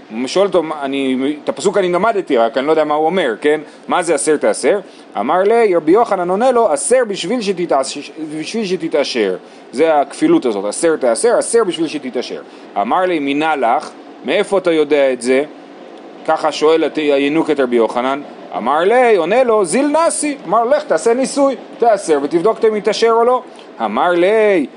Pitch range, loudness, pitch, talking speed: 150-250 Hz, -15 LUFS, 185 Hz, 170 wpm